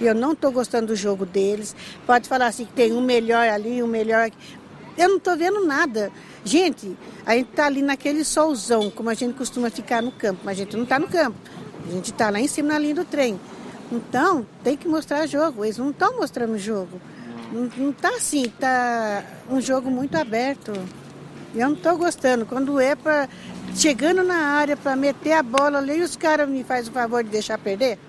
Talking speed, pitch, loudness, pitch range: 205 wpm, 255 Hz, -22 LUFS, 225-295 Hz